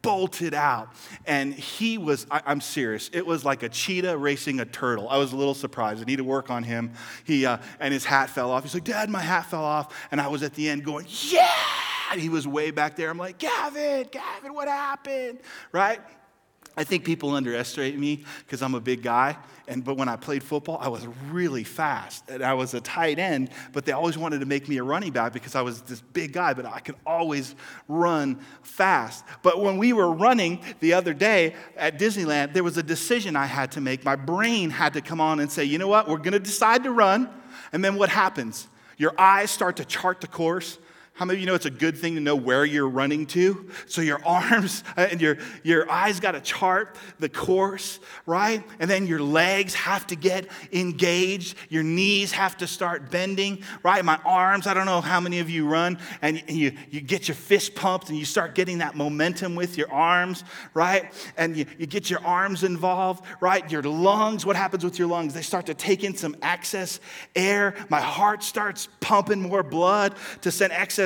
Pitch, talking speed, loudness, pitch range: 170 Hz, 220 wpm, -24 LUFS, 145-195 Hz